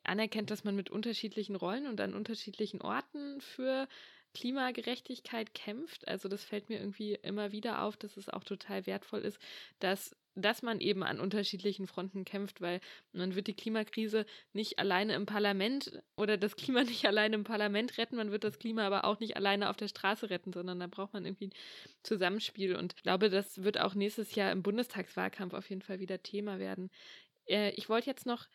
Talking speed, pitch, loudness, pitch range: 190 wpm, 210 Hz, -36 LUFS, 195-220 Hz